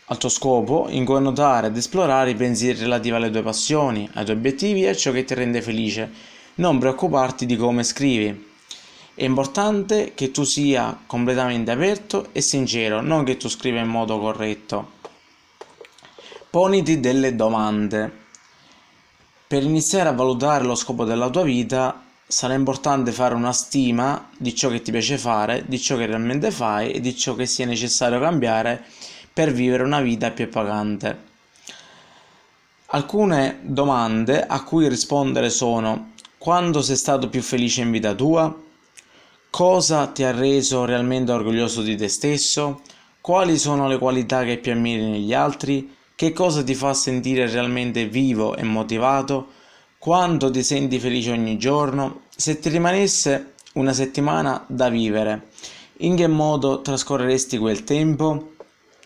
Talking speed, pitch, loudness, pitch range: 150 wpm, 130 Hz, -21 LUFS, 120-145 Hz